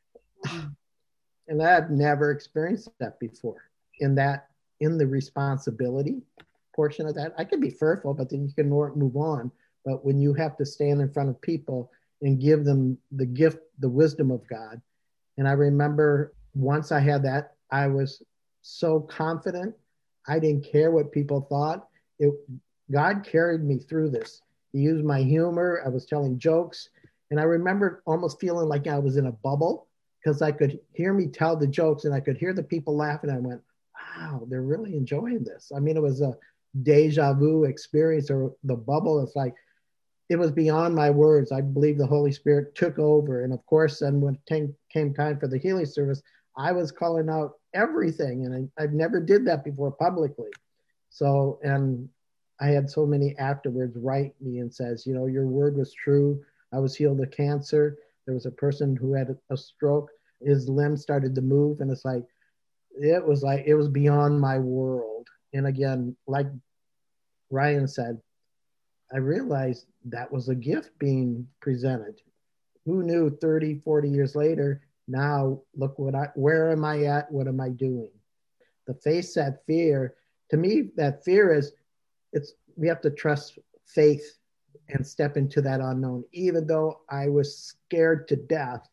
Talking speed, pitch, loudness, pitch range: 180 wpm, 145 Hz, -25 LUFS, 135-155 Hz